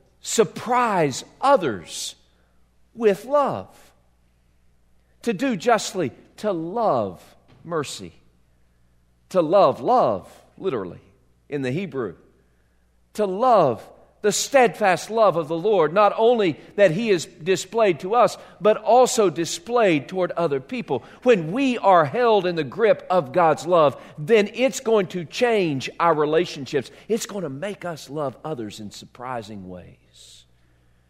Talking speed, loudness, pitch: 125 wpm, -21 LUFS, 170 Hz